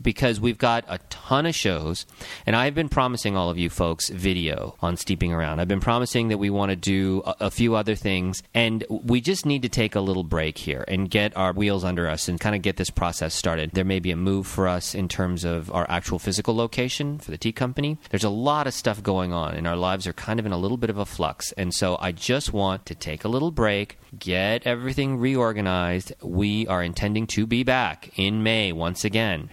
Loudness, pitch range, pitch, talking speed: -24 LUFS, 90-115 Hz, 100 Hz, 235 wpm